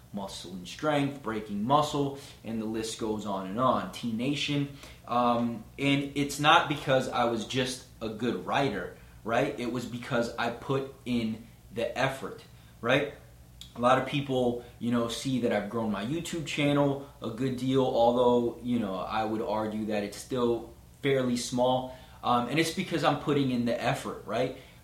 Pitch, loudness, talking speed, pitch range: 120 Hz, -29 LUFS, 175 wpm, 110-140 Hz